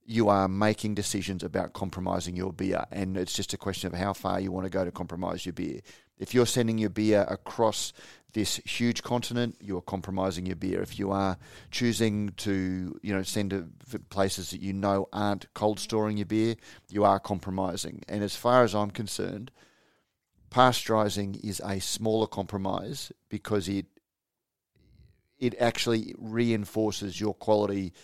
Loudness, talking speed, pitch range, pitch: -29 LUFS, 165 wpm, 95-110 Hz, 100 Hz